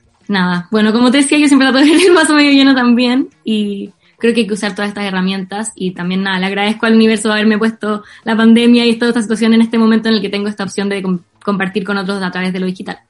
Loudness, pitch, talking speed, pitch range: -12 LUFS, 215 Hz, 270 wpm, 200-235 Hz